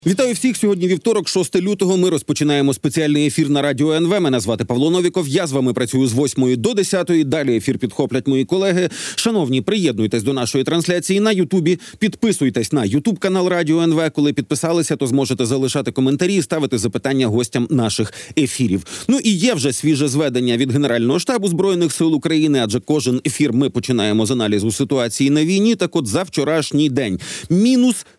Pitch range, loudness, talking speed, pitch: 130-180 Hz, -17 LUFS, 175 wpm, 150 Hz